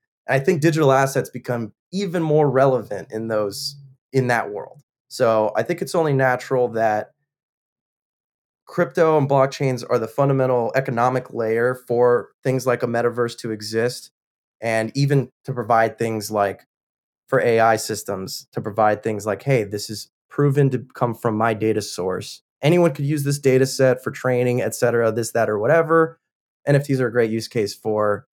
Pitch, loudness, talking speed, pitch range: 125 Hz, -21 LUFS, 165 wpm, 110-140 Hz